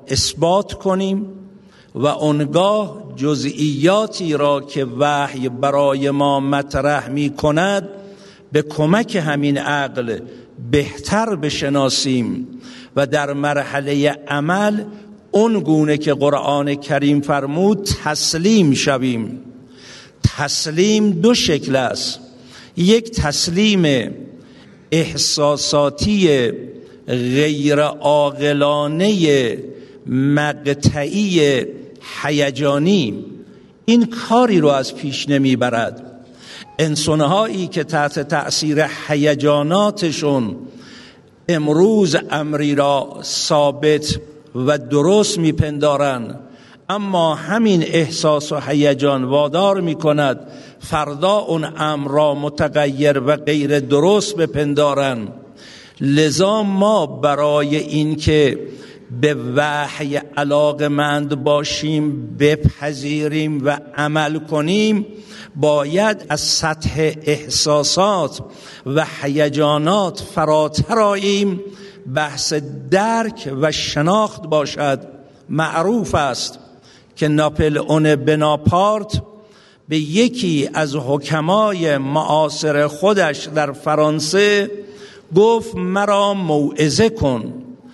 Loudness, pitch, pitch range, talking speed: -17 LUFS, 150 Hz, 145-185 Hz, 85 wpm